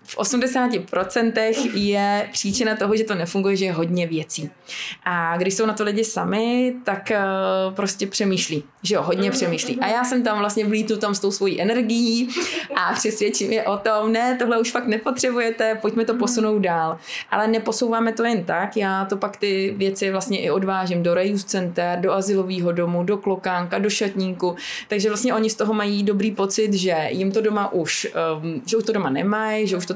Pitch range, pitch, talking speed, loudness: 190-225 Hz, 205 Hz, 190 wpm, -21 LUFS